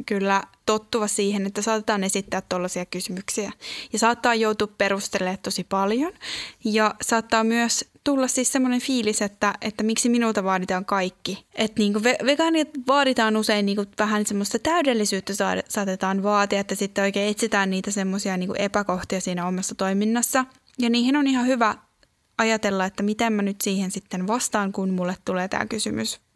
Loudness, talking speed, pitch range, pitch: -23 LUFS, 155 wpm, 195-230 Hz, 210 Hz